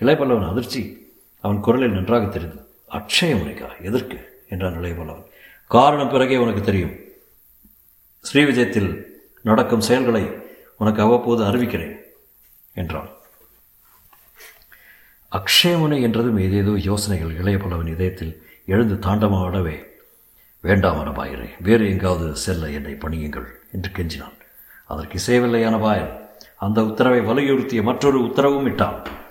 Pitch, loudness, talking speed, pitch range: 100 Hz, -20 LUFS, 100 wpm, 90-120 Hz